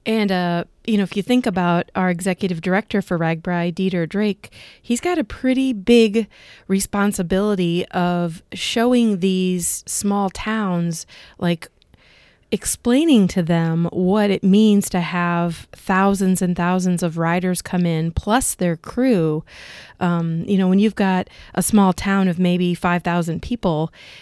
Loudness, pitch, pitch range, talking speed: -19 LUFS, 185 Hz, 175-205 Hz, 145 wpm